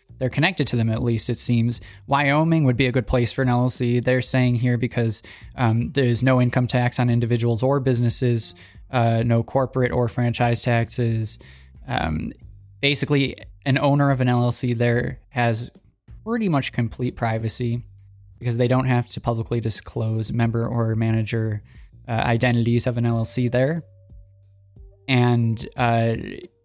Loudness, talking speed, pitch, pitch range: -21 LUFS, 150 wpm, 120 Hz, 115-125 Hz